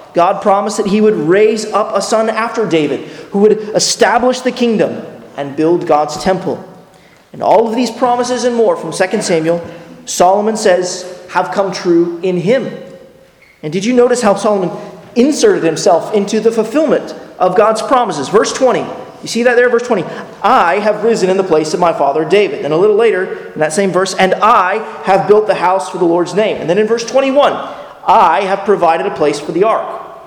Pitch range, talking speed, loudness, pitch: 180-235 Hz, 200 wpm, -12 LUFS, 205 Hz